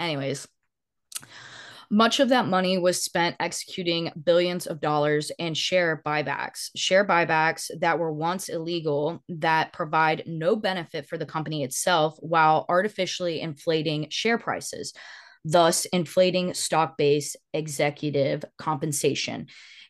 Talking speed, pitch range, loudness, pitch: 120 wpm, 155-180 Hz, -25 LUFS, 165 Hz